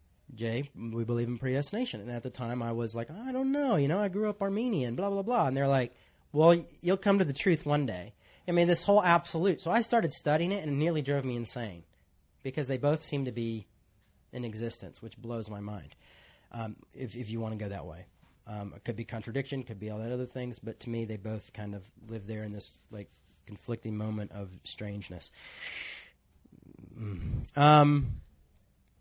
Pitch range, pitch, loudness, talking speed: 105-145 Hz, 115 Hz, -31 LUFS, 210 wpm